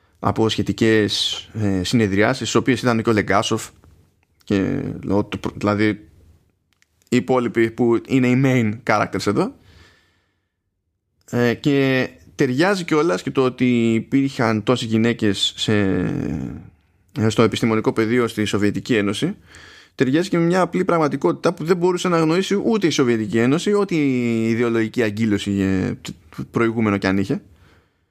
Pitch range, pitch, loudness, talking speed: 100-130 Hz, 110 Hz, -19 LUFS, 130 wpm